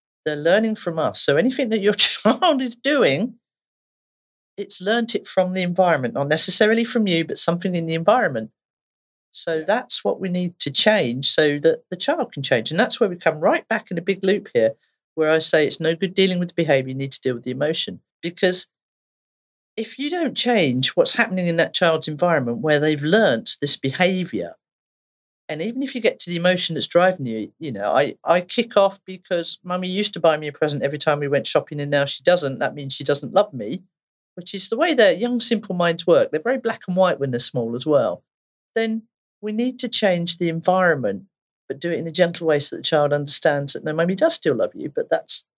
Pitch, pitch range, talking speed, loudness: 180 Hz, 155-215 Hz, 225 wpm, -20 LUFS